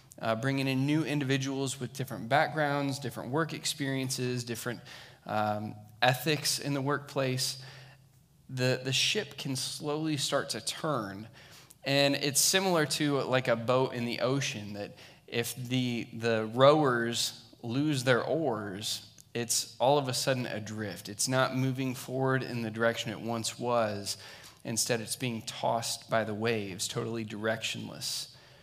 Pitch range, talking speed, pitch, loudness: 115-140 Hz, 145 wpm, 130 Hz, -30 LUFS